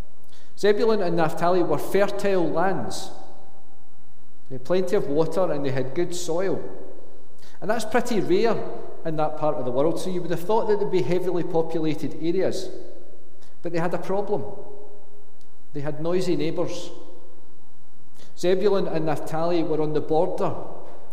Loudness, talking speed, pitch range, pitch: -25 LUFS, 150 wpm, 155-190 Hz, 170 Hz